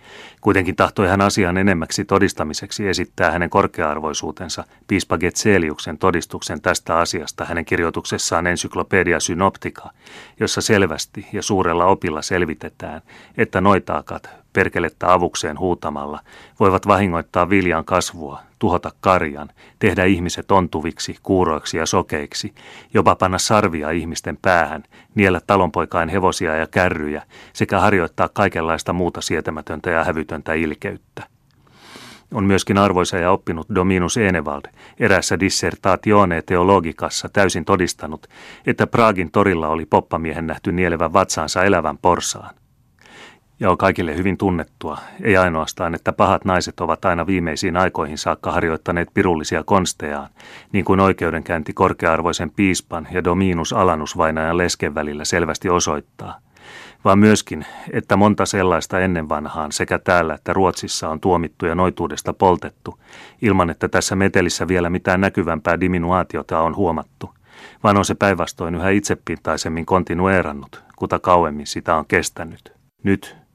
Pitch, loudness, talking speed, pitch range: 90 Hz, -19 LUFS, 120 wpm, 80-95 Hz